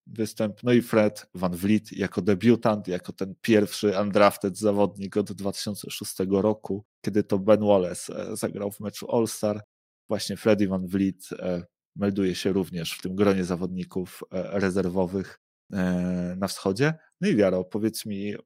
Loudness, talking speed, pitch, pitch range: -26 LUFS, 140 wpm, 100 Hz, 95-105 Hz